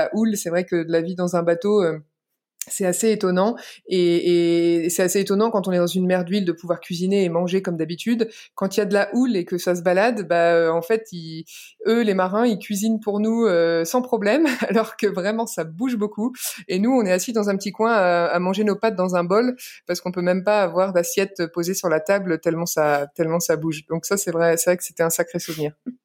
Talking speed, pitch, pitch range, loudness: 245 wpm, 185 Hz, 170-215 Hz, -21 LUFS